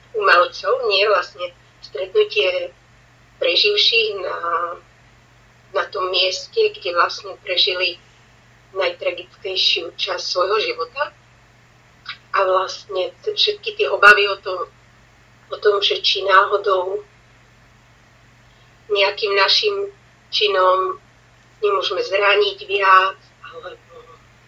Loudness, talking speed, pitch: -17 LUFS, 85 wpm, 195 Hz